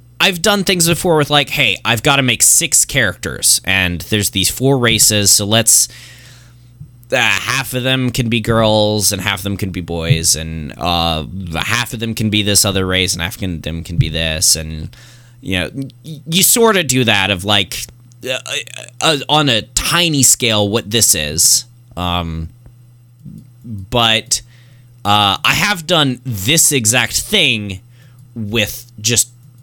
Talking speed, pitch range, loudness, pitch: 165 wpm, 100-130 Hz, -13 LUFS, 120 Hz